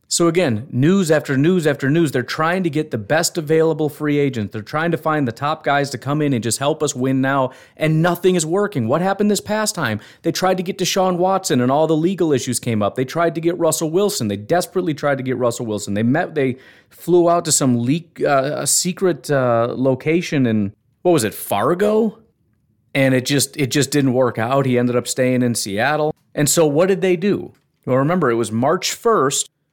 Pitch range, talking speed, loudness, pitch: 125-170 Hz, 225 wpm, -18 LUFS, 145 Hz